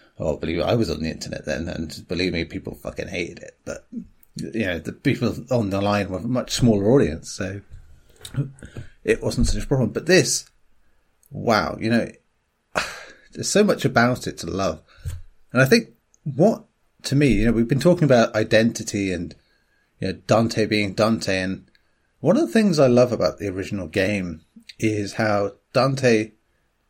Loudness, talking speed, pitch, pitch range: -22 LUFS, 180 wpm, 105 Hz, 95-120 Hz